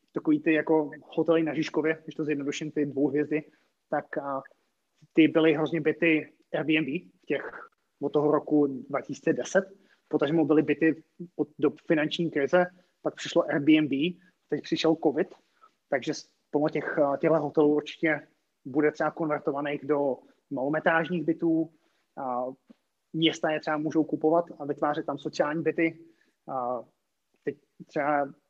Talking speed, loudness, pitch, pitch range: 135 wpm, -28 LUFS, 155 Hz, 150-165 Hz